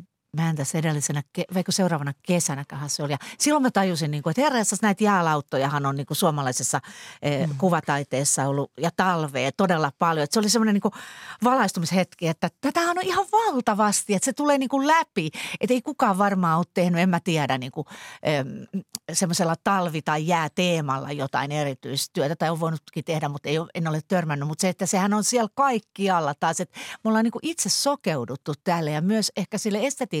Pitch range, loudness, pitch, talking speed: 150-210 Hz, -24 LUFS, 175 Hz, 160 wpm